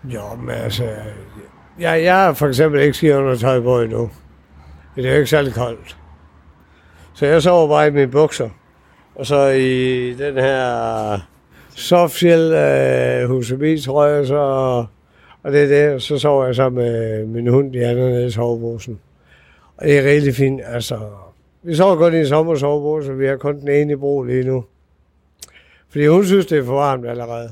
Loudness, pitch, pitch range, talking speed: -16 LUFS, 130 Hz, 105-145 Hz, 175 wpm